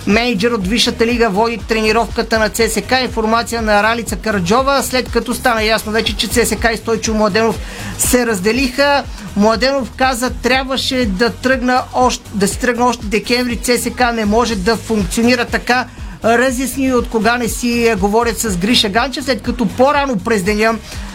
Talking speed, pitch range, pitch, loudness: 155 wpm, 225-245 Hz, 230 Hz, -14 LUFS